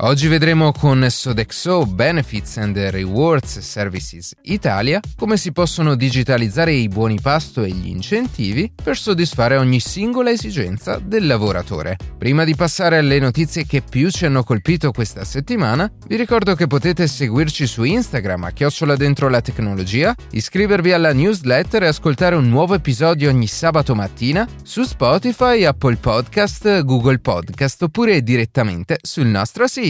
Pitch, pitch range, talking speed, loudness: 140 Hz, 115-170 Hz, 145 wpm, -17 LUFS